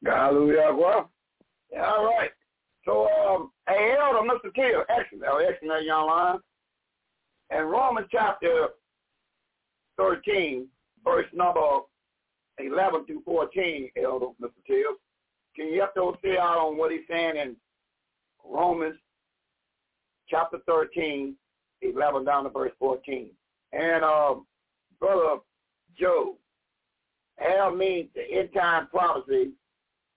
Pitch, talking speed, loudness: 175 Hz, 105 wpm, -25 LUFS